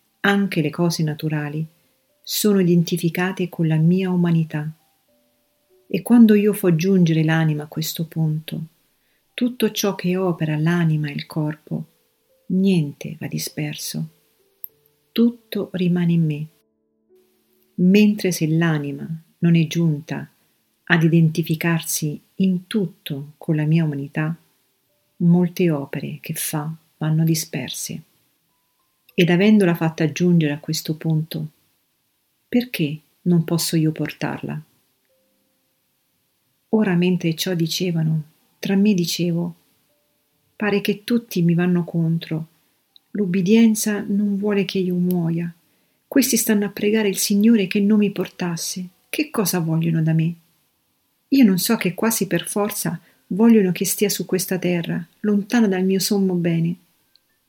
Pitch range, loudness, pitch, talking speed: 155-195 Hz, -20 LUFS, 170 Hz, 125 wpm